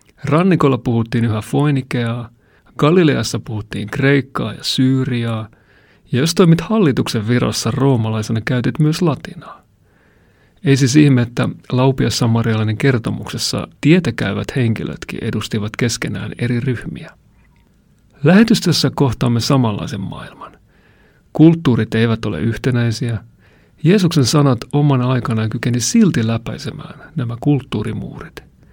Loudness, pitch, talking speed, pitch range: -16 LUFS, 125 Hz, 100 wpm, 115-140 Hz